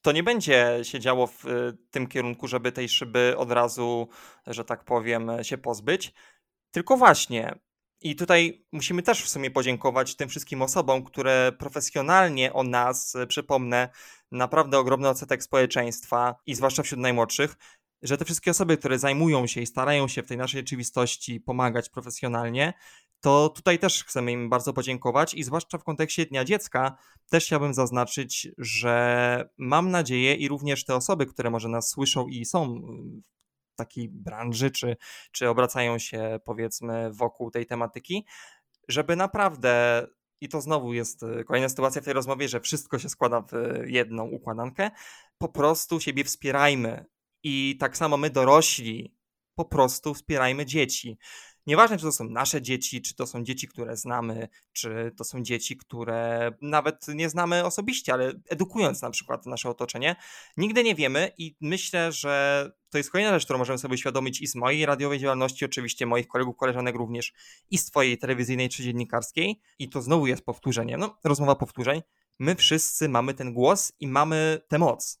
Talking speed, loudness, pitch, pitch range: 165 wpm, -25 LUFS, 130 Hz, 120-155 Hz